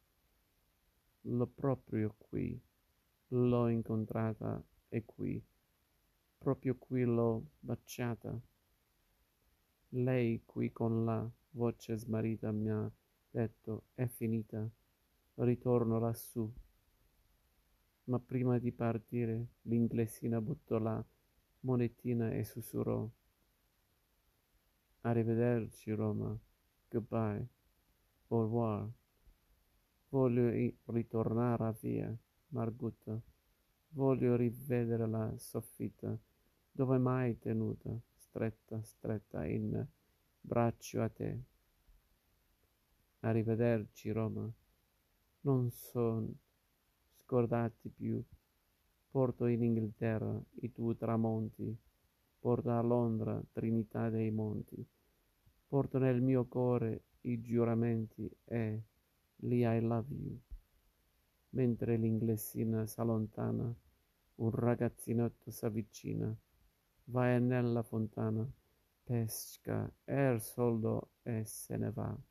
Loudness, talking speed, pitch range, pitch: -37 LUFS, 85 wpm, 110-120 Hz, 115 Hz